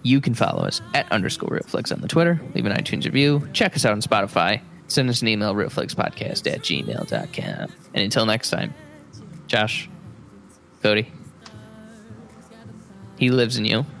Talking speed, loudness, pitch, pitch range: 155 wpm, -22 LUFS, 125 Hz, 110-155 Hz